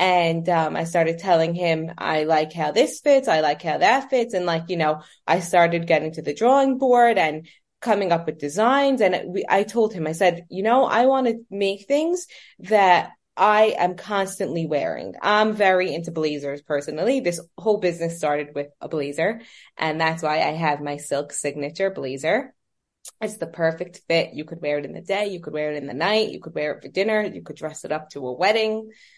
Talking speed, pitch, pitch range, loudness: 215 wpm, 170 Hz, 155-210 Hz, -22 LUFS